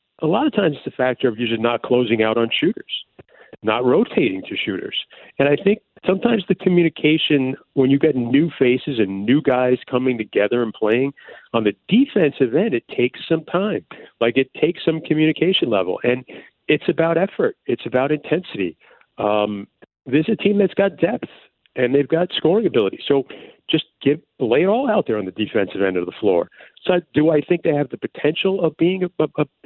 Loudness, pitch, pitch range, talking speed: -19 LUFS, 145 Hz, 125-165 Hz, 195 wpm